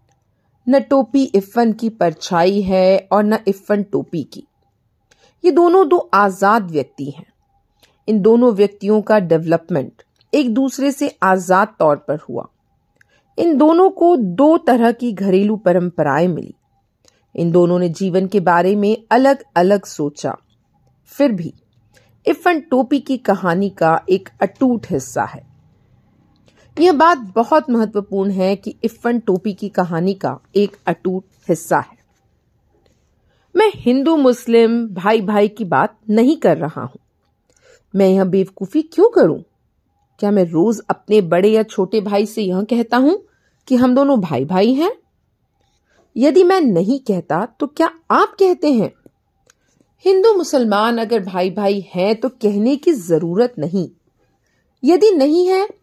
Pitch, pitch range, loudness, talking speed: 210 Hz, 185-265 Hz, -16 LUFS, 140 wpm